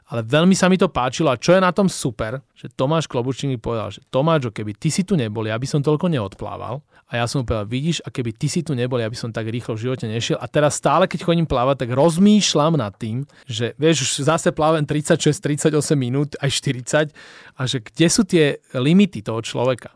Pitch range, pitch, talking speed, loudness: 120-160 Hz, 140 Hz, 230 wpm, -20 LUFS